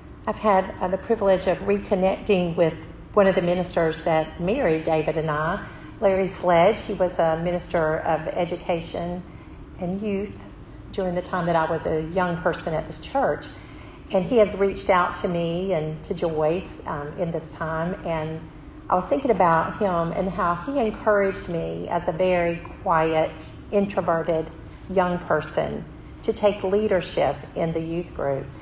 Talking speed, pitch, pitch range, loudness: 160 wpm, 175 Hz, 160-195 Hz, -24 LUFS